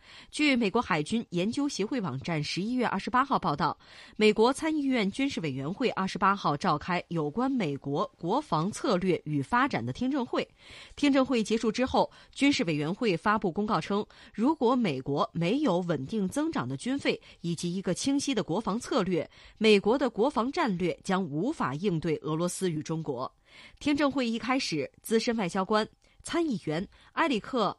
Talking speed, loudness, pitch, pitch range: 275 characters per minute, -29 LUFS, 210 Hz, 170-255 Hz